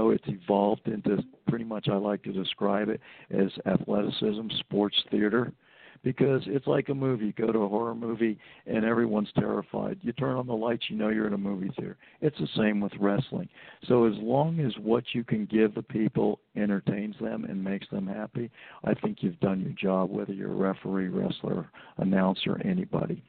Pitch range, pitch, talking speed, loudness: 100-120 Hz, 110 Hz, 190 wpm, -29 LUFS